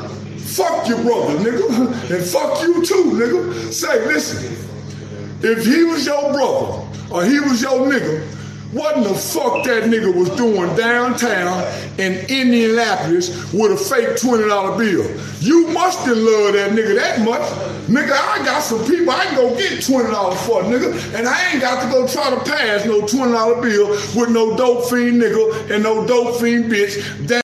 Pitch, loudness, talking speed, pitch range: 235 Hz, -16 LUFS, 175 wpm, 210-275 Hz